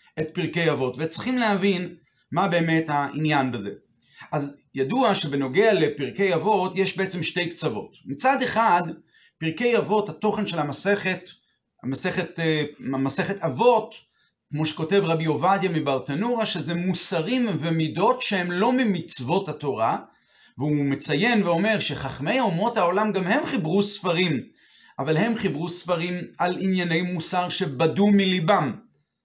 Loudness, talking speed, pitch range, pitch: -24 LUFS, 120 wpm, 155-200 Hz, 175 Hz